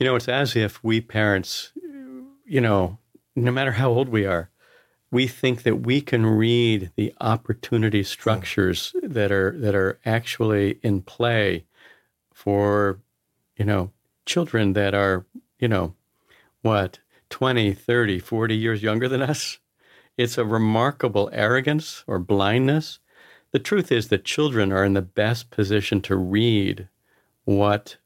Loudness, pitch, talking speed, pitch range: -22 LUFS, 110 Hz, 140 wpm, 100-125 Hz